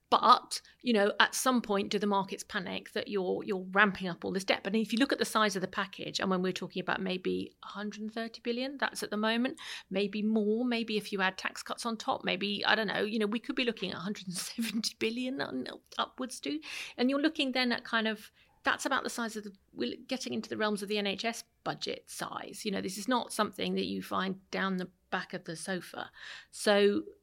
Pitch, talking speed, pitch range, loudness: 215 Hz, 230 wpm, 195-235 Hz, -32 LUFS